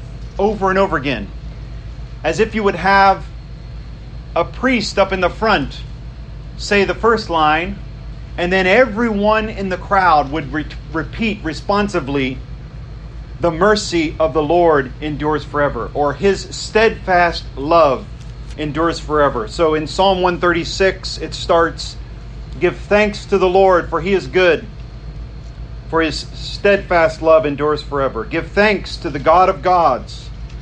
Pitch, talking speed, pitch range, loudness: 165 Hz, 135 wpm, 145-195 Hz, -16 LUFS